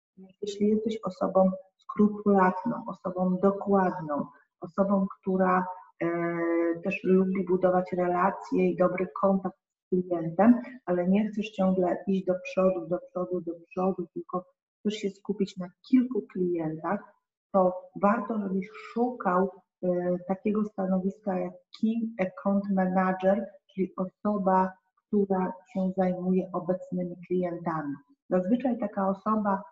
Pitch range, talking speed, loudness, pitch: 180-200 Hz, 110 wpm, -28 LUFS, 190 Hz